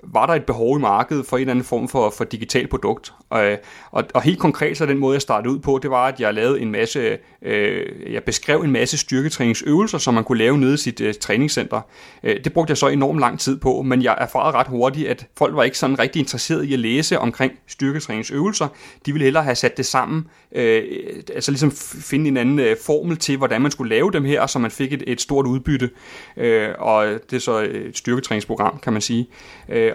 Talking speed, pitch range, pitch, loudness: 230 wpm, 125-150 Hz, 135 Hz, -19 LUFS